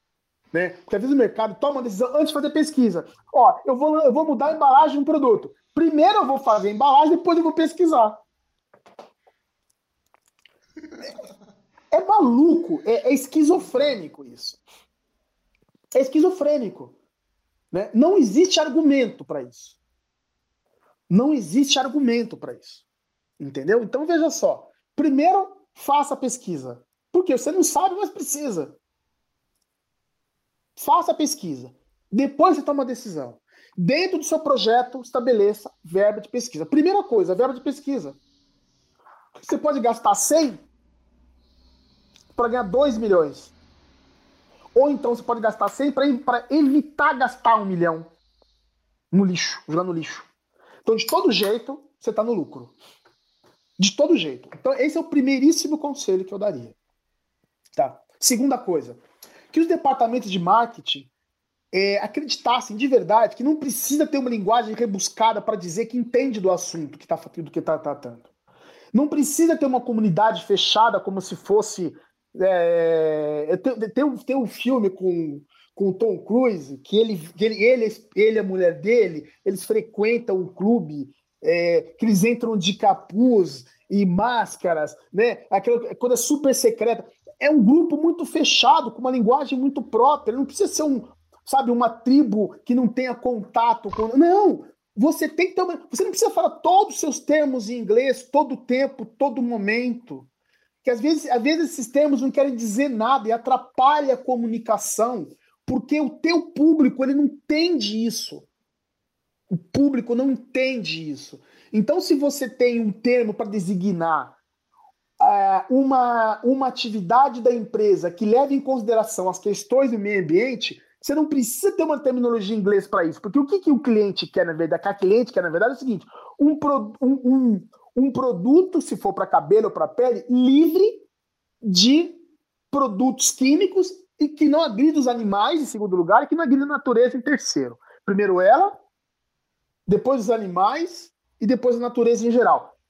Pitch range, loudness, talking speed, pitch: 210-295 Hz, -21 LUFS, 160 wpm, 250 Hz